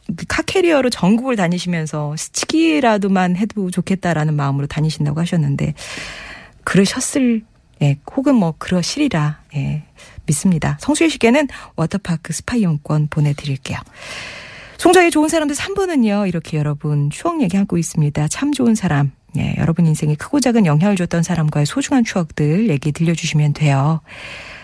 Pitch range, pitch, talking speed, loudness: 150-235 Hz, 175 Hz, 355 characters per minute, -17 LUFS